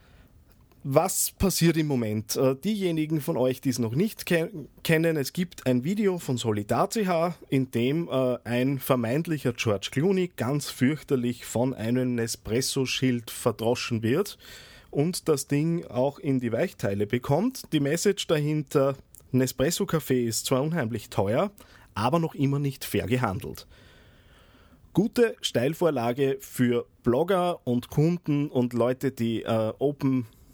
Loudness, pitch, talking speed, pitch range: -26 LUFS, 130 Hz, 125 wpm, 120-160 Hz